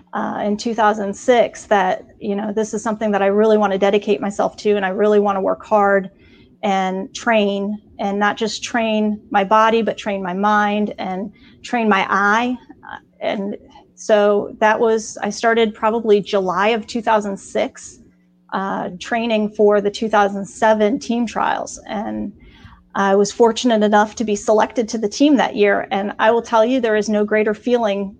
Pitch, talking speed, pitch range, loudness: 210 Hz, 170 wpm, 200-225 Hz, -18 LUFS